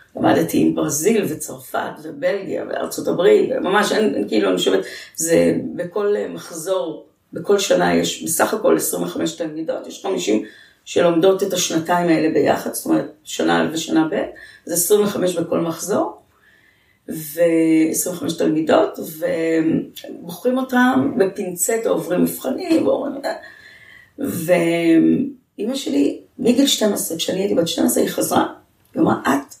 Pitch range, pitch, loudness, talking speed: 165-235 Hz, 180 Hz, -19 LUFS, 120 wpm